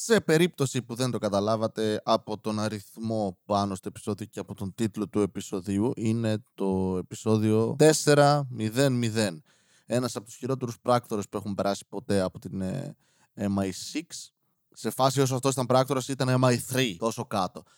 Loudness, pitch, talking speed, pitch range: -27 LUFS, 110 Hz, 150 wpm, 100-130 Hz